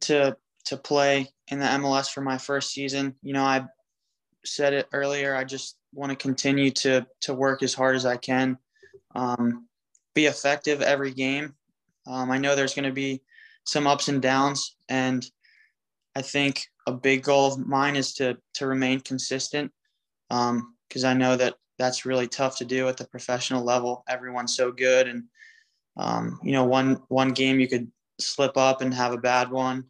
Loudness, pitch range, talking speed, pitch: -25 LUFS, 130-140 Hz, 185 wpm, 135 Hz